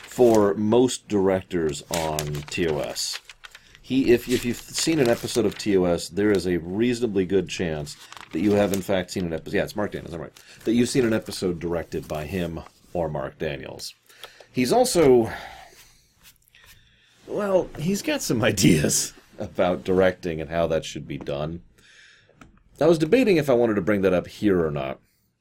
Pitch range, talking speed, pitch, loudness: 85-120 Hz, 170 wpm, 100 Hz, -23 LUFS